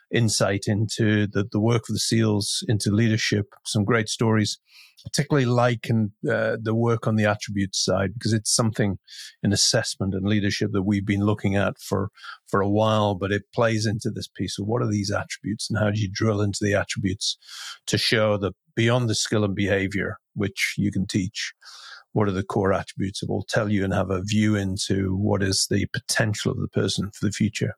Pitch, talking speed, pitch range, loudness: 105 Hz, 210 wpm, 100-115 Hz, -24 LUFS